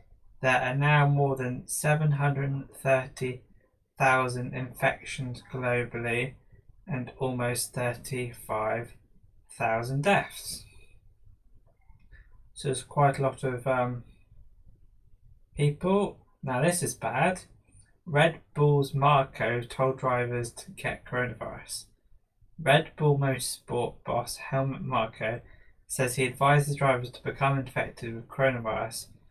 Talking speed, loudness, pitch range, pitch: 95 wpm, -28 LUFS, 110-135 Hz, 125 Hz